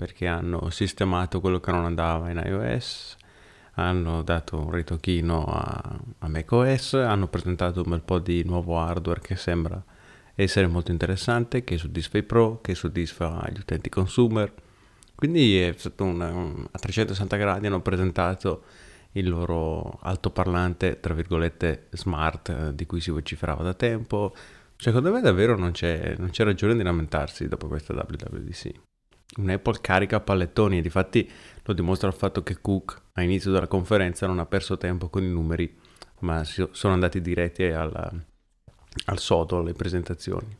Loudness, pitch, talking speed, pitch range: -26 LUFS, 90 Hz, 155 wpm, 85-100 Hz